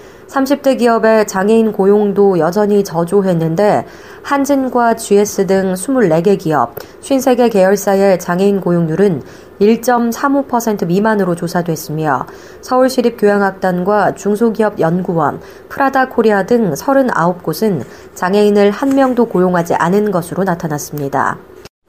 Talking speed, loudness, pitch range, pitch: 260 characters per minute, -13 LUFS, 180-240 Hz, 205 Hz